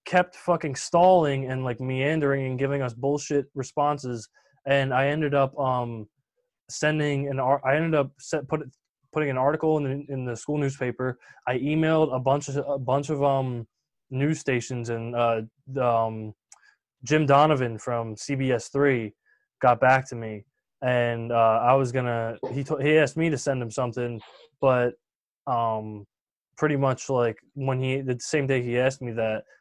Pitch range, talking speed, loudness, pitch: 120-145 Hz, 175 wpm, -25 LUFS, 135 Hz